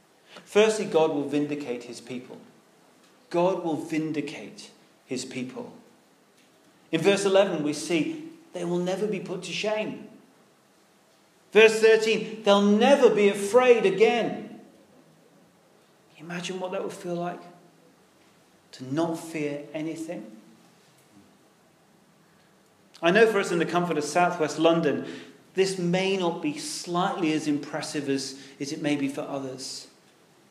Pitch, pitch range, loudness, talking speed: 170 Hz, 150-200 Hz, -25 LUFS, 130 wpm